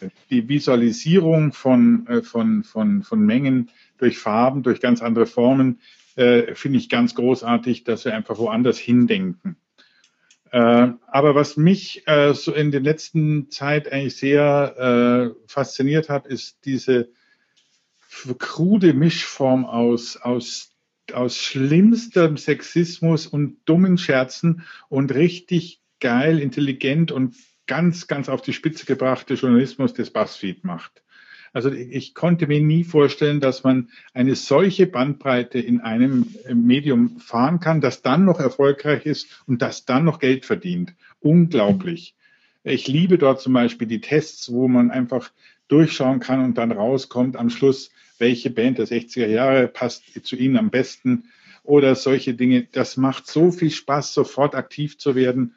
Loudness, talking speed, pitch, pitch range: -19 LUFS, 145 wpm, 140 Hz, 125-165 Hz